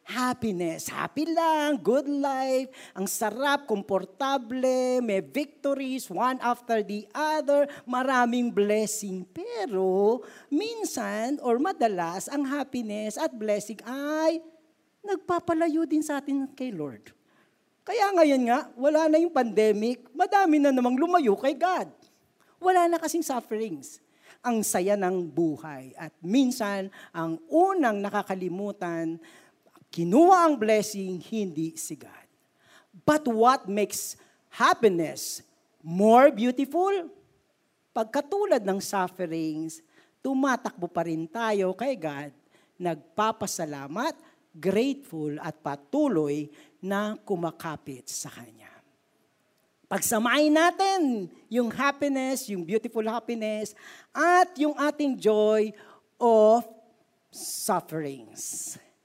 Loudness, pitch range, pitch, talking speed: -26 LUFS, 195-285 Hz, 235 Hz, 100 wpm